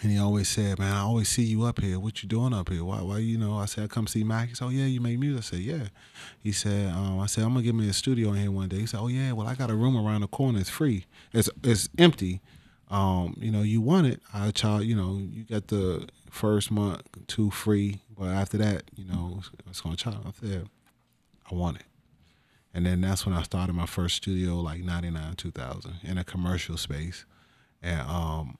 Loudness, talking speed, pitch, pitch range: -28 LUFS, 250 wpm, 100 Hz, 90-110 Hz